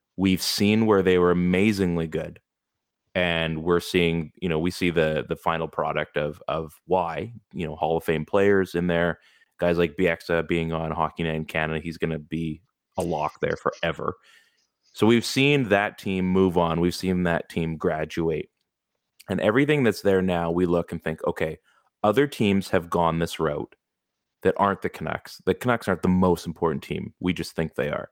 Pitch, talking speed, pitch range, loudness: 85 Hz, 190 wpm, 80-95 Hz, -24 LUFS